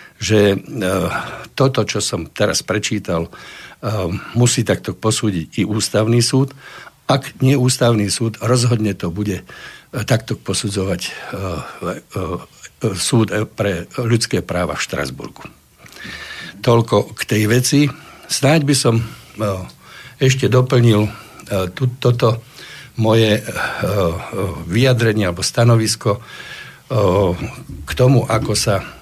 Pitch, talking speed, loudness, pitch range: 115 Hz, 95 wpm, -17 LUFS, 105-125 Hz